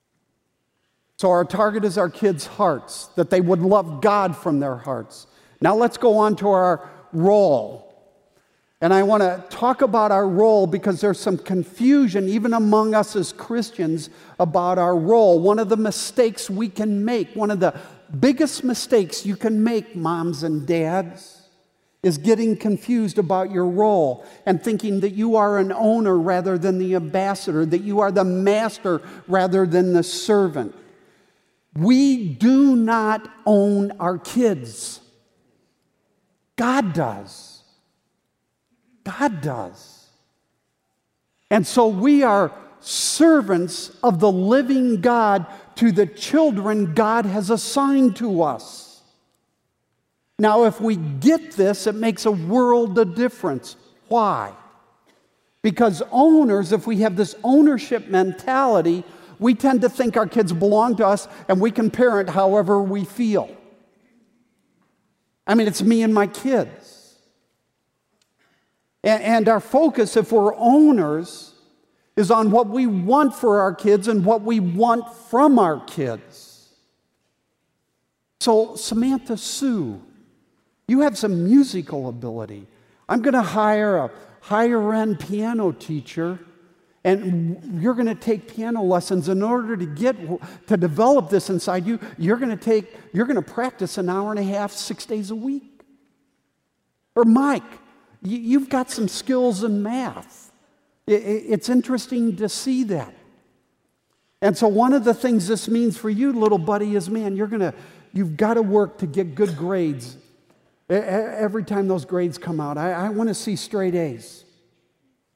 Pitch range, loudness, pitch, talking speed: 185-230 Hz, -20 LUFS, 210 Hz, 145 wpm